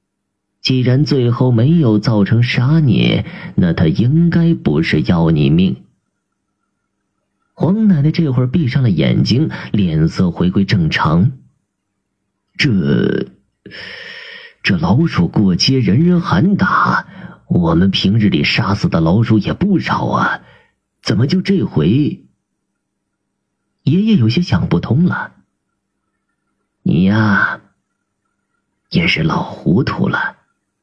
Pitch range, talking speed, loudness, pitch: 125-180 Hz, 160 characters per minute, -14 LUFS, 160 Hz